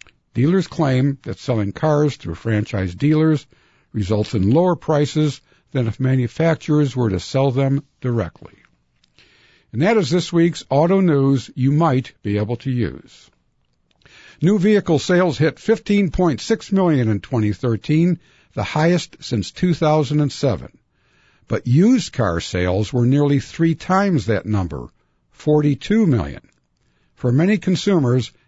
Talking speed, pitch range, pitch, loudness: 125 wpm, 115-165 Hz, 140 Hz, -19 LUFS